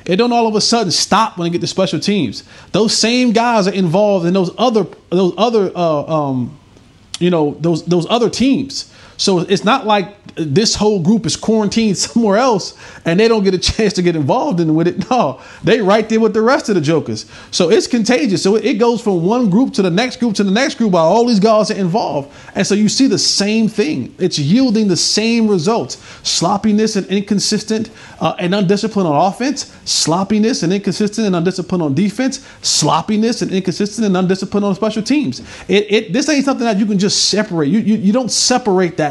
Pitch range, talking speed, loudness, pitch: 180-225 Hz, 215 wpm, -14 LUFS, 205 Hz